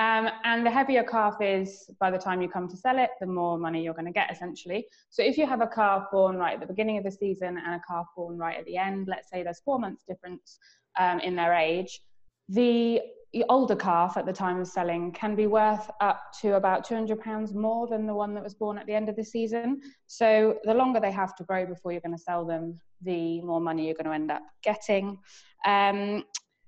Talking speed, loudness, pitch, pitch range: 235 wpm, -28 LUFS, 200 Hz, 180-220 Hz